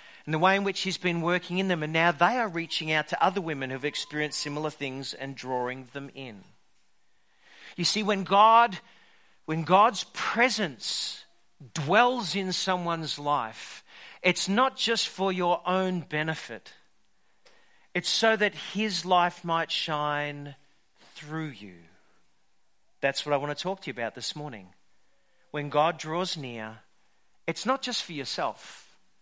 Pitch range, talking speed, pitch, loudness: 145-190 Hz, 150 wpm, 165 Hz, -27 LUFS